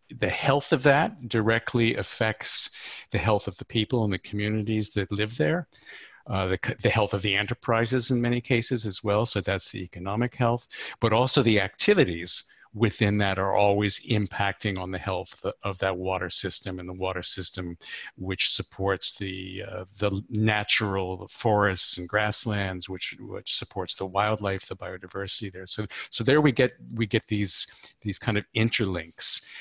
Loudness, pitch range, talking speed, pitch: -26 LUFS, 95-115 Hz, 170 wpm, 105 Hz